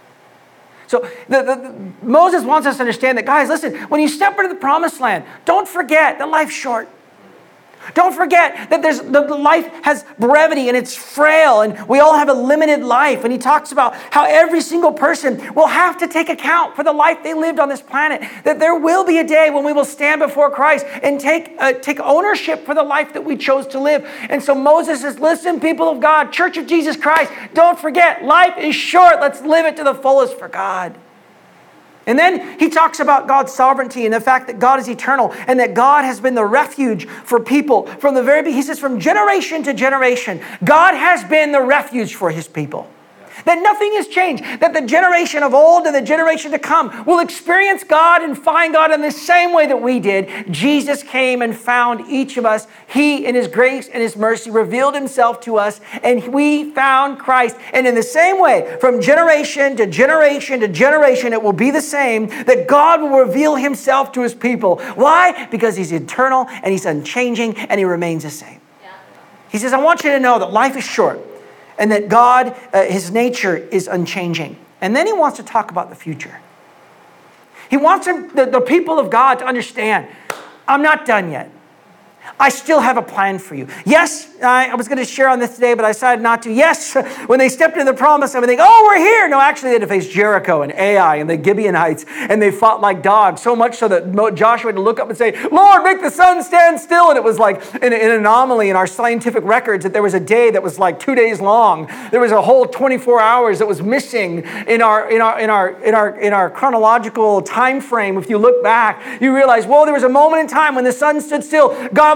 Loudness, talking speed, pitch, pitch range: -13 LUFS, 220 wpm, 270 Hz, 230-310 Hz